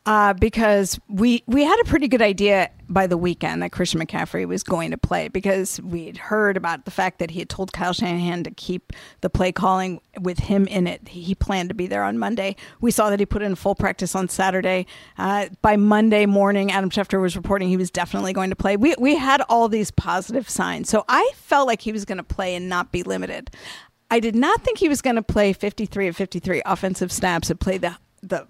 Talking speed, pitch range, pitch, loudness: 235 wpm, 180-215 Hz, 195 Hz, -21 LUFS